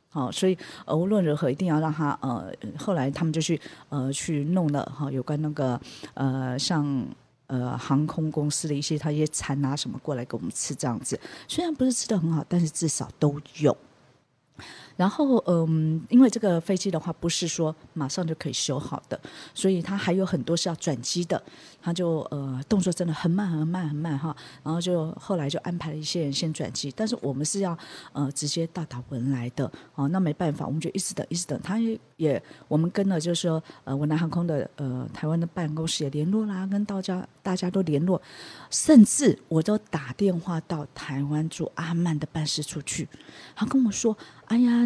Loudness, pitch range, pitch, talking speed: -27 LUFS, 145-180 Hz, 160 Hz, 295 characters per minute